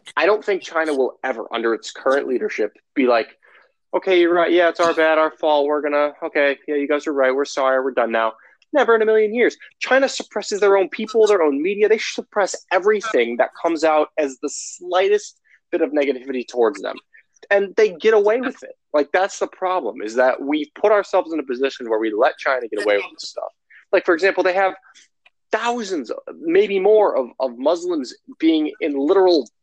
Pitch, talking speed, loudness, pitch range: 185 Hz, 210 wpm, -19 LUFS, 150-220 Hz